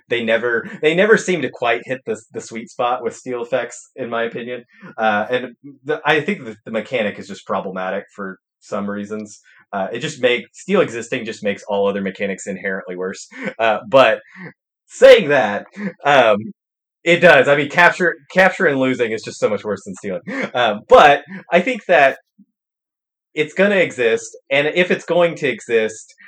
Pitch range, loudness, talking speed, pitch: 115-190 Hz, -17 LUFS, 185 wpm, 150 Hz